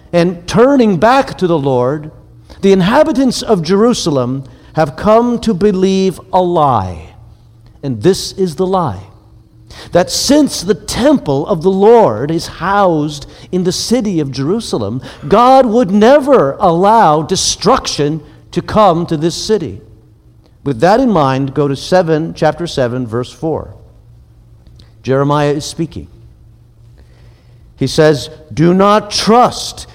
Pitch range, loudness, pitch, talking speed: 125-195 Hz, -12 LUFS, 160 Hz, 130 wpm